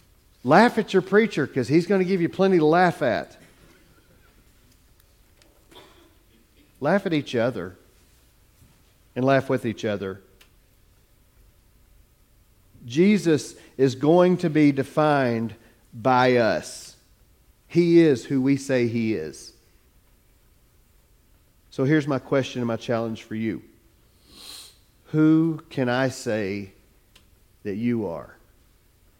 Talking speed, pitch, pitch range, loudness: 110 wpm, 120 Hz, 100-150 Hz, -22 LUFS